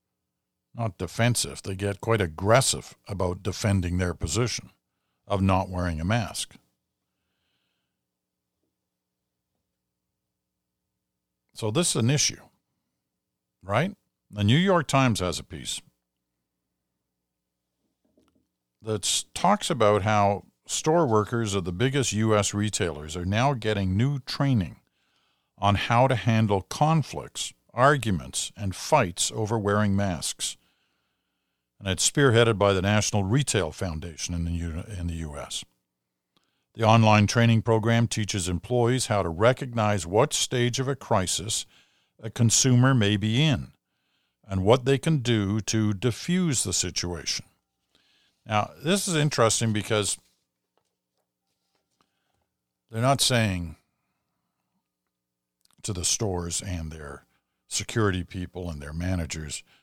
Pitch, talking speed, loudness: 100 Hz, 115 wpm, -25 LUFS